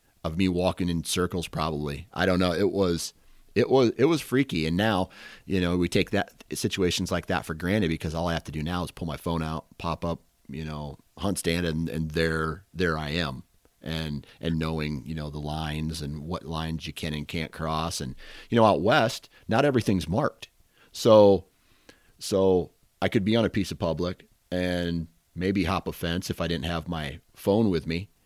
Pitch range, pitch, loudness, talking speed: 80-95 Hz, 85 Hz, -27 LUFS, 210 wpm